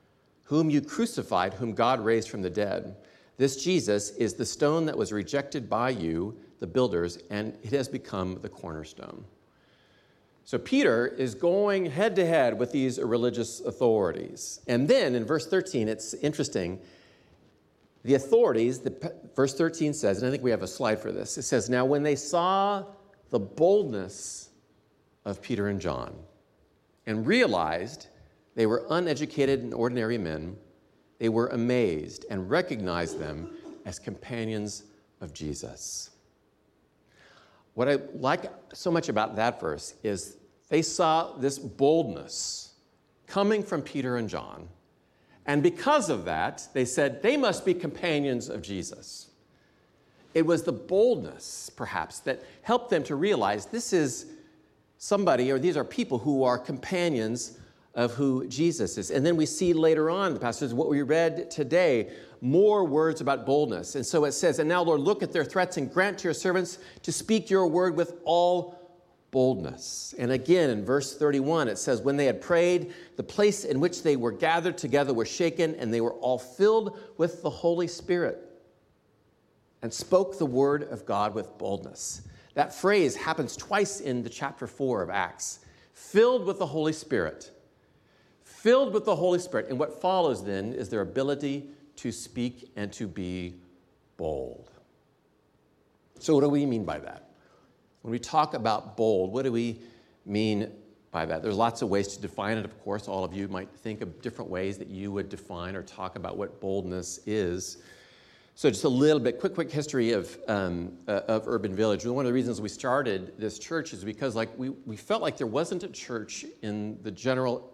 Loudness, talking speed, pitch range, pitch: -28 LUFS, 170 wpm, 110-165 Hz, 130 Hz